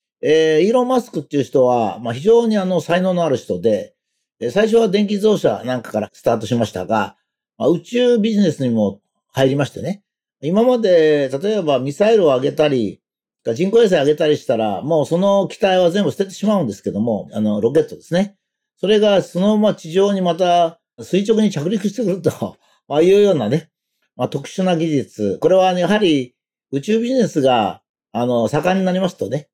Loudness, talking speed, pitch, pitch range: -17 LUFS, 380 characters per minute, 180 Hz, 140-210 Hz